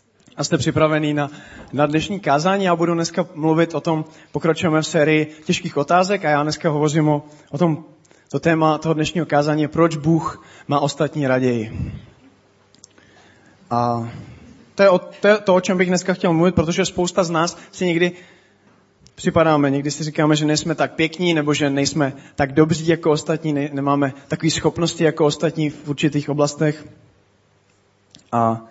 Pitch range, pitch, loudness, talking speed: 145-170 Hz, 155 Hz, -19 LUFS, 165 wpm